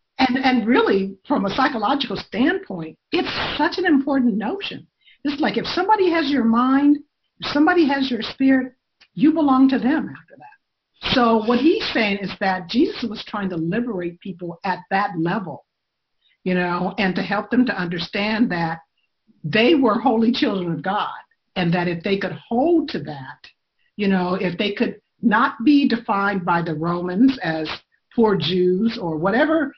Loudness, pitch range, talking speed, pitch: -20 LUFS, 185-275 Hz, 170 wpm, 225 Hz